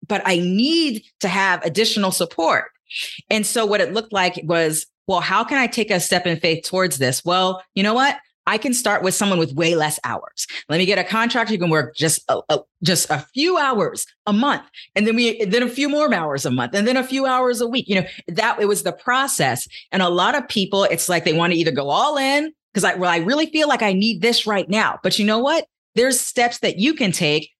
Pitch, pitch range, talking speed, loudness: 205 Hz, 175-240 Hz, 250 wpm, -19 LUFS